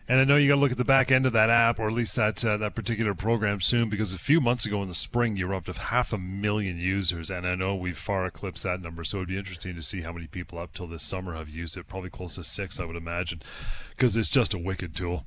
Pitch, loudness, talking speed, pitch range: 95 Hz, -27 LUFS, 300 wpm, 90-115 Hz